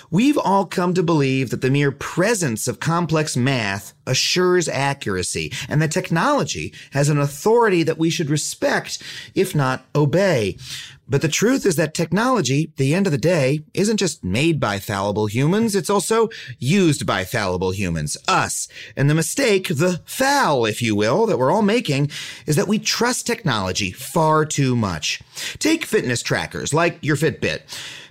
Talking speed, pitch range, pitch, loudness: 165 wpm, 130-180 Hz, 155 Hz, -20 LUFS